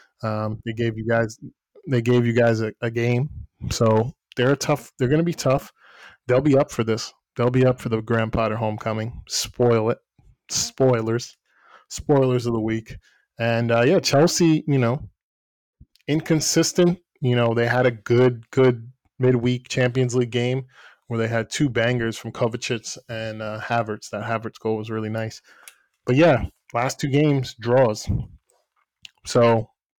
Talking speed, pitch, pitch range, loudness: 165 wpm, 120 Hz, 115-130 Hz, -22 LUFS